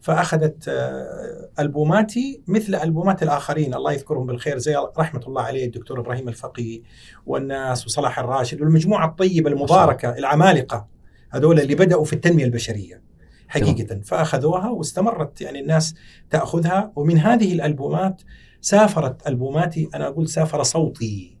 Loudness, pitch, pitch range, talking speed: -20 LUFS, 150 Hz, 125-165 Hz, 120 wpm